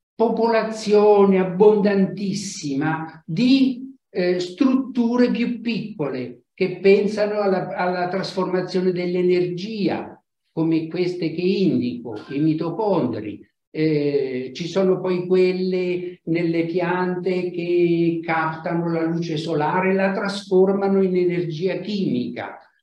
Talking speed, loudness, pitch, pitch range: 95 wpm, -21 LUFS, 180 Hz, 165-195 Hz